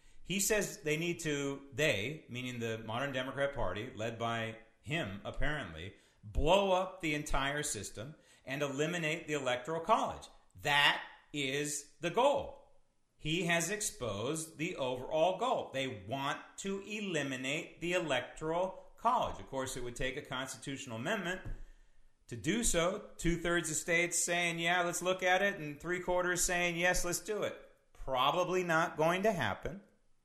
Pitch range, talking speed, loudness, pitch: 135-180 Hz, 150 wpm, -34 LUFS, 160 Hz